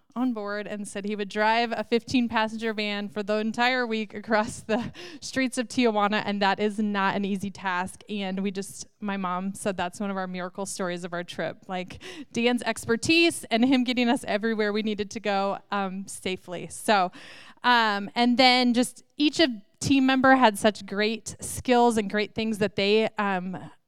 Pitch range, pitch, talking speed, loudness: 200-240 Hz, 215 Hz, 190 wpm, -25 LUFS